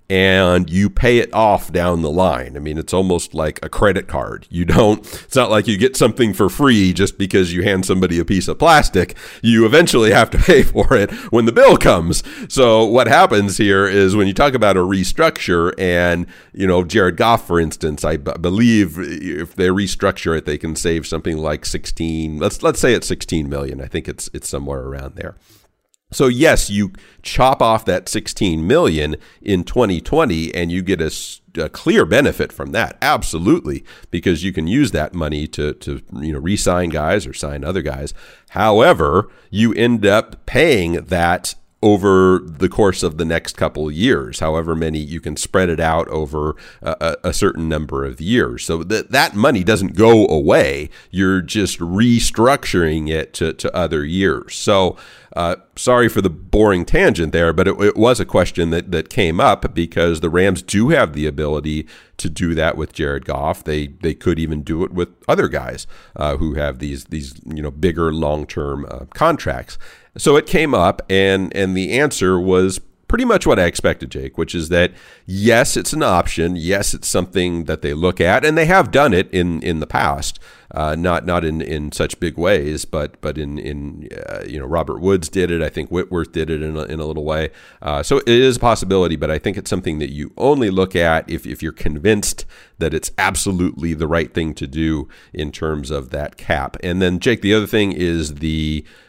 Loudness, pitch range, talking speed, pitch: -16 LUFS, 80-95 Hz, 200 wpm, 85 Hz